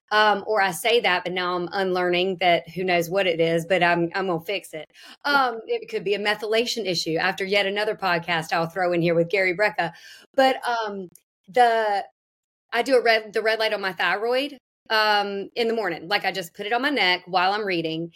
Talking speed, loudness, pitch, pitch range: 220 wpm, -23 LUFS, 195 Hz, 175-225 Hz